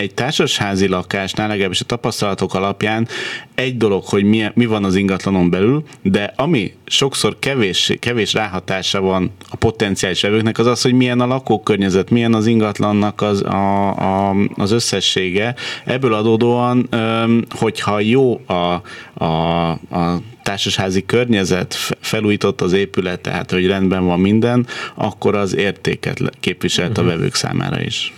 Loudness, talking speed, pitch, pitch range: -17 LUFS, 135 wpm, 105 Hz, 95-115 Hz